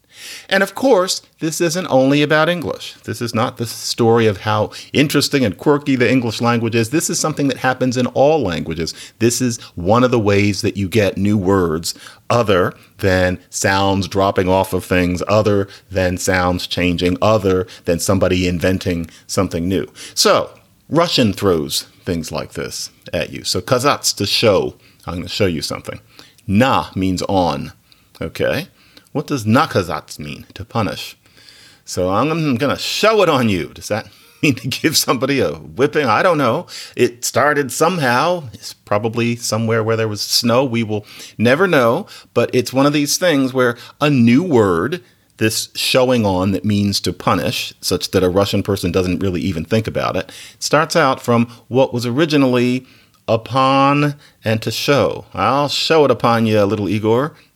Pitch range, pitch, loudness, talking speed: 95-130 Hz, 115 Hz, -17 LUFS, 170 wpm